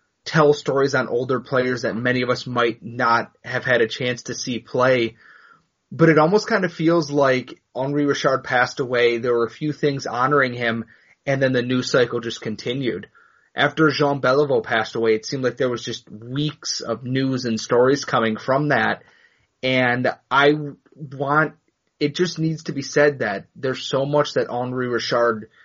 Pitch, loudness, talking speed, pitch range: 130 Hz, -21 LUFS, 180 wpm, 120-145 Hz